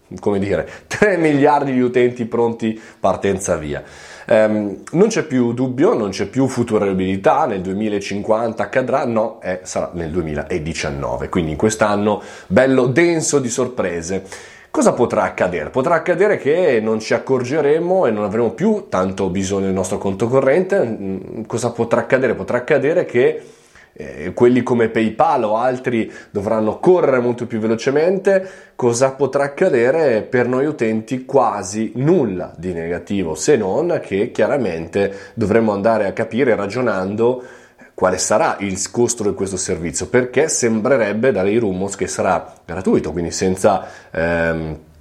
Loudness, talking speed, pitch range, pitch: -18 LUFS, 140 wpm, 95-130 Hz, 110 Hz